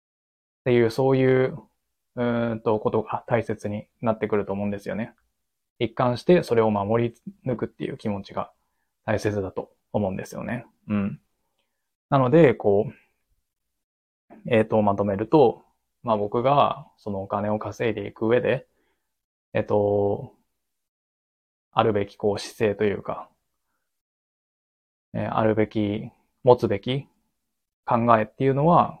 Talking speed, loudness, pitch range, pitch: 255 characters per minute, -24 LUFS, 105-120 Hz, 110 Hz